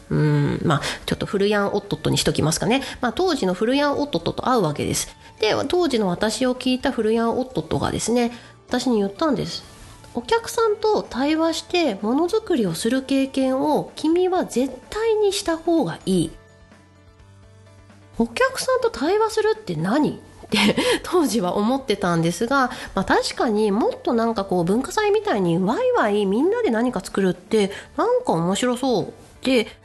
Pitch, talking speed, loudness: 250 Hz, 325 characters per minute, -21 LUFS